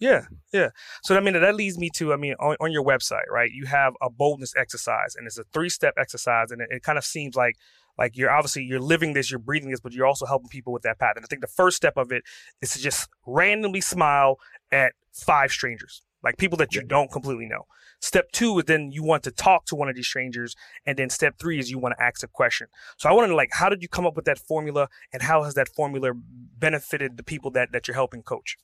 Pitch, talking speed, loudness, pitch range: 140 Hz, 260 wpm, -24 LUFS, 130-160 Hz